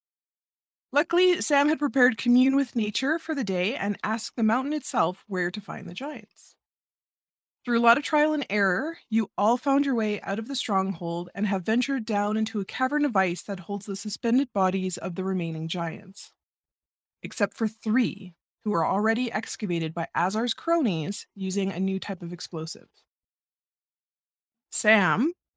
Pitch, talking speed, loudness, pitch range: 215 Hz, 165 wpm, -26 LUFS, 190-255 Hz